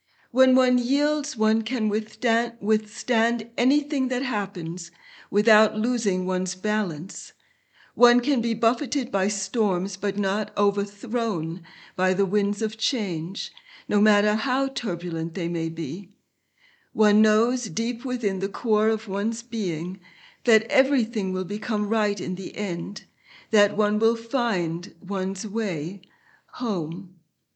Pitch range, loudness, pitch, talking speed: 190-235 Hz, -24 LUFS, 215 Hz, 125 wpm